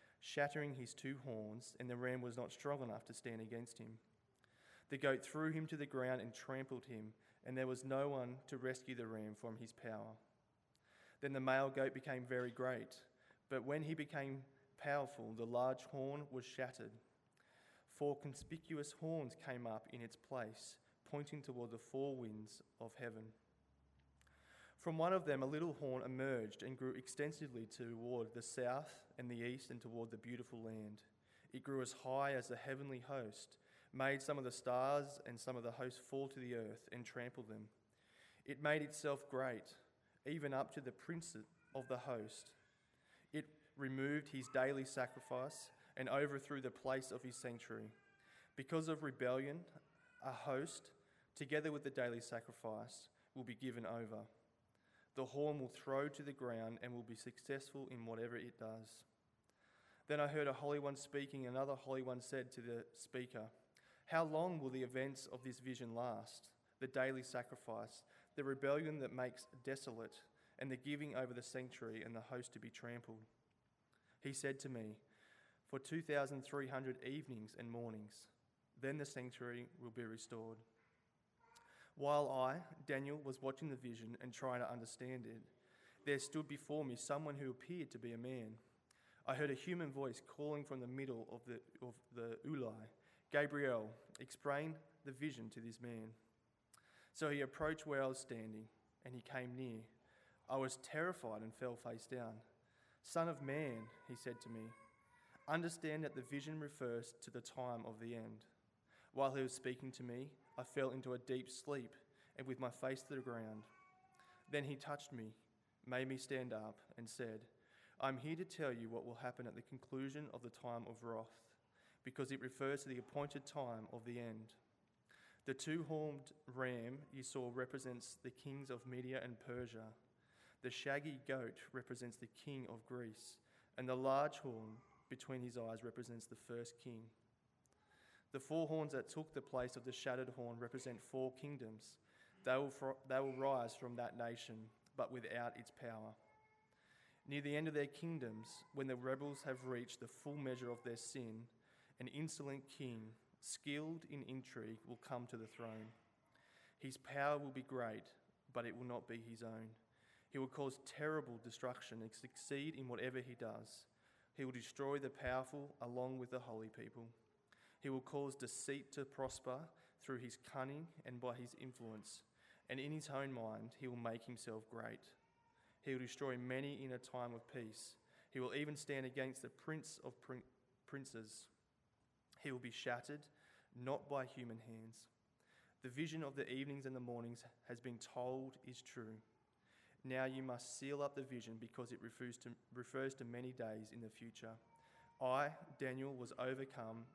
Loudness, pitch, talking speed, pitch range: -48 LUFS, 130 Hz, 170 wpm, 120-140 Hz